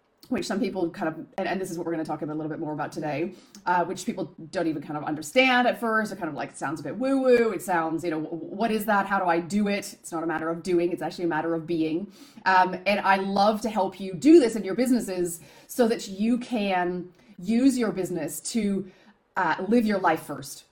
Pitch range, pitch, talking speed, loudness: 165-220 Hz, 185 Hz, 260 wpm, -26 LUFS